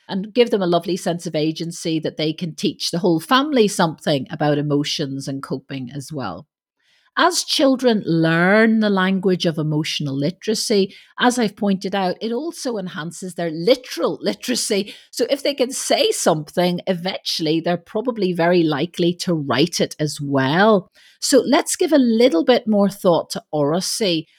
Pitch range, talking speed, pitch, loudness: 160-225 Hz, 160 wpm, 180 Hz, -19 LUFS